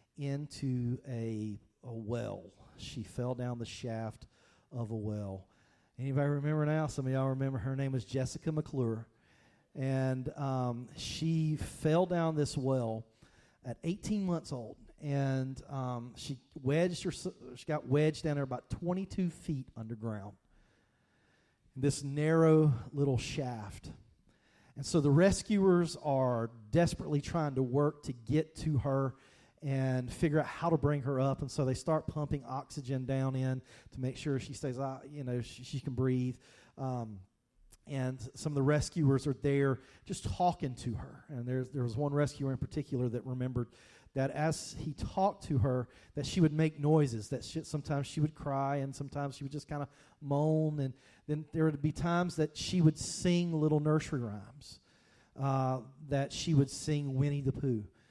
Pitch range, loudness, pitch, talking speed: 125-150 Hz, -34 LUFS, 135 Hz, 170 wpm